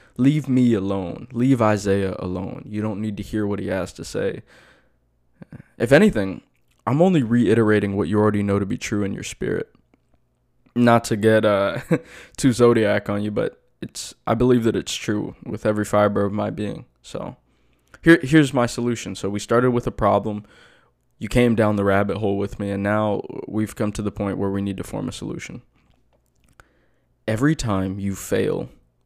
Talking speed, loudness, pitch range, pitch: 185 wpm, -21 LUFS, 100-120 Hz, 105 Hz